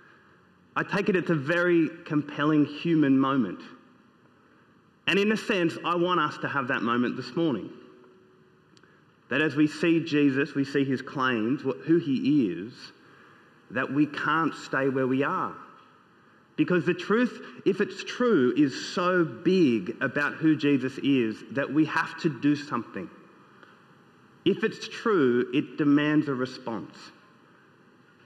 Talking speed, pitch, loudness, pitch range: 140 wpm, 160 Hz, -26 LUFS, 140-180 Hz